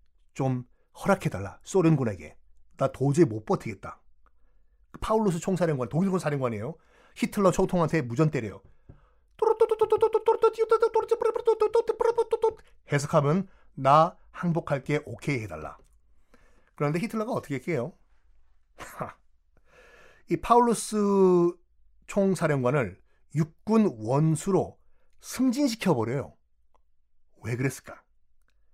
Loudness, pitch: -26 LUFS, 160 Hz